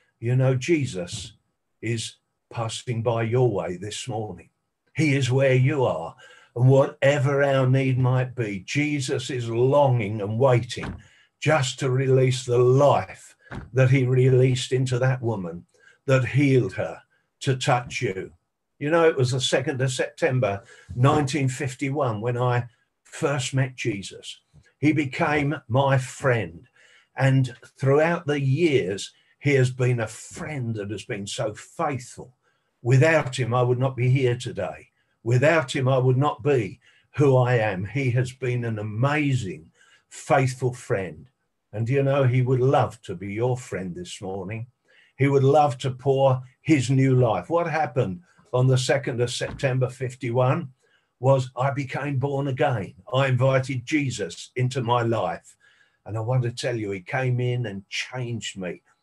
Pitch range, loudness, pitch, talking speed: 120-140 Hz, -23 LUFS, 130 Hz, 150 wpm